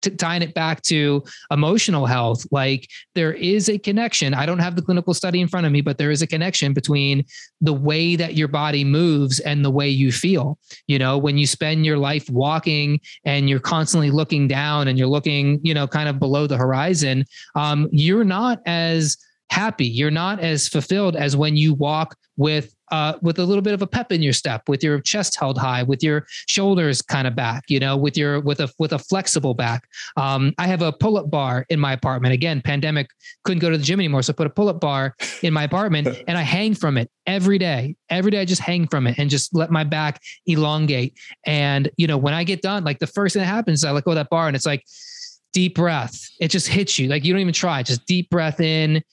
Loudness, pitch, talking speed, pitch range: -20 LUFS, 155 Hz, 235 wpm, 140-175 Hz